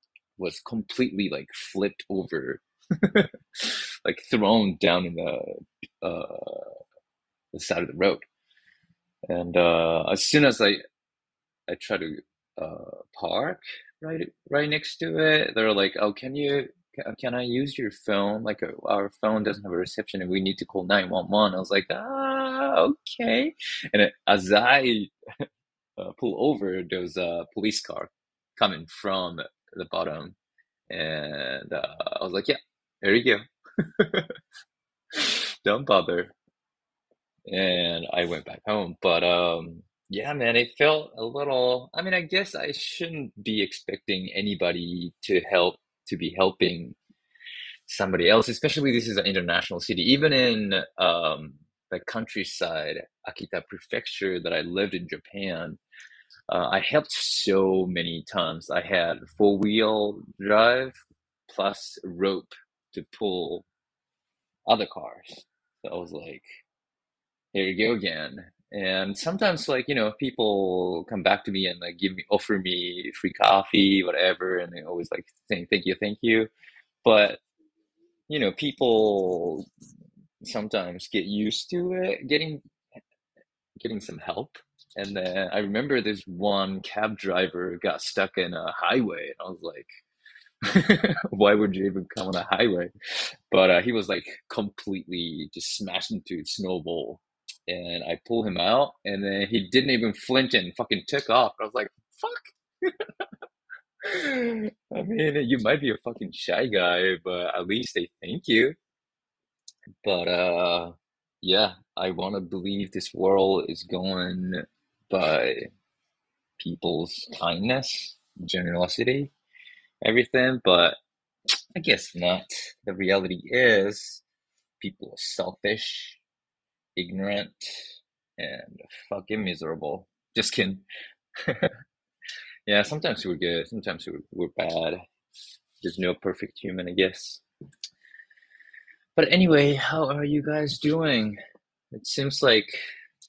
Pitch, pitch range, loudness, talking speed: 105 Hz, 95-145 Hz, -25 LUFS, 135 wpm